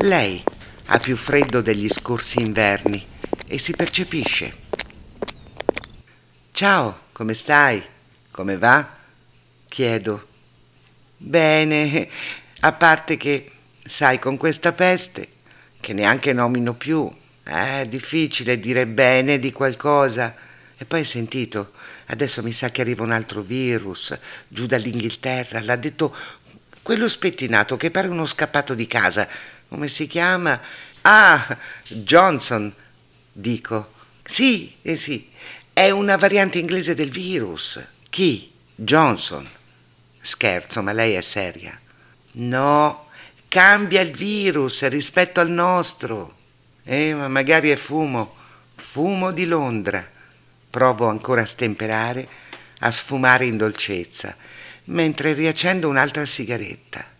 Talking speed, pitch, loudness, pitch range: 110 wpm, 130 Hz, -18 LUFS, 115-160 Hz